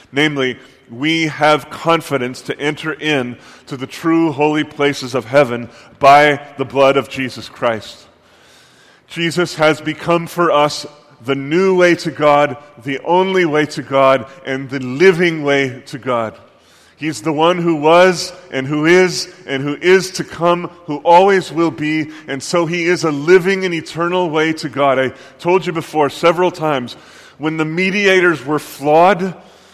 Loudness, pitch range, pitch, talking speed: -15 LUFS, 135-170 Hz, 155 Hz, 160 wpm